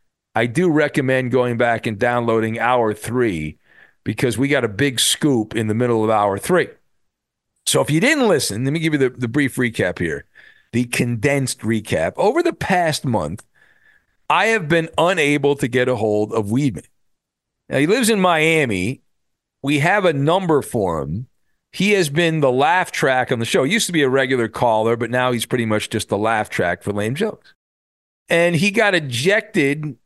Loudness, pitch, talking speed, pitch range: -18 LUFS, 125 Hz, 190 wpm, 110-155 Hz